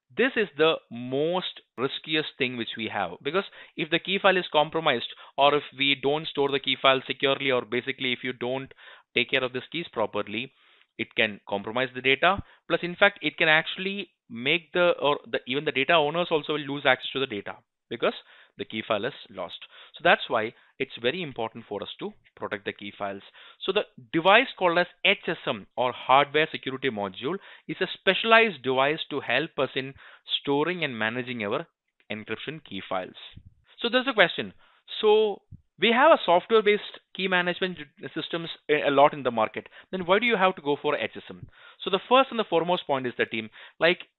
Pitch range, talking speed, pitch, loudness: 130-180 Hz, 195 wpm, 150 Hz, -25 LUFS